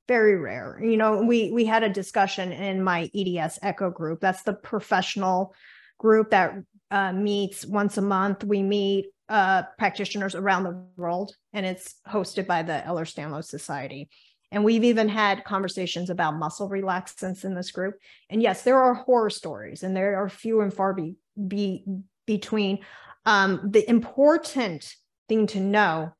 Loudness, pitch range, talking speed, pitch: -25 LUFS, 185-210 Hz, 165 wpm, 195 Hz